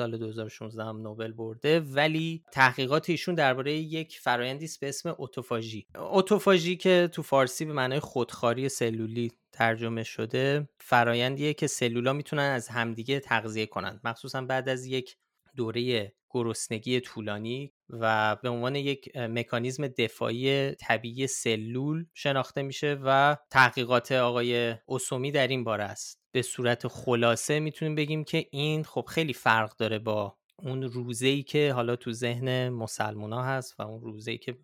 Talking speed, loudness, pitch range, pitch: 145 wpm, -29 LUFS, 115-140 Hz, 125 Hz